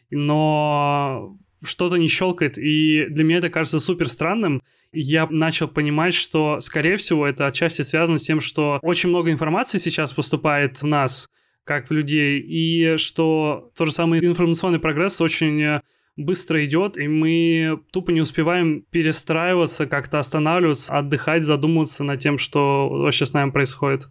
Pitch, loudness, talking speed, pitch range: 155 Hz, -20 LUFS, 150 wpm, 145-165 Hz